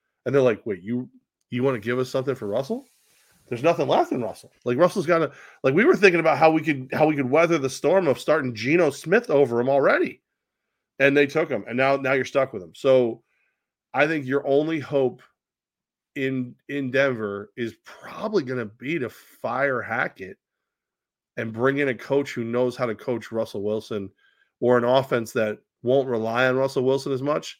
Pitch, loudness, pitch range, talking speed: 135 Hz, -23 LUFS, 120-145 Hz, 205 wpm